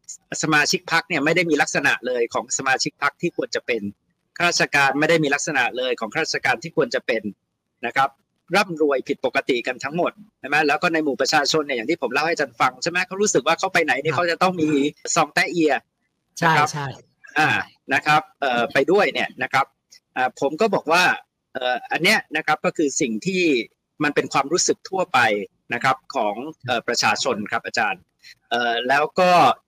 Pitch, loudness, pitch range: 155 Hz, -21 LUFS, 140-180 Hz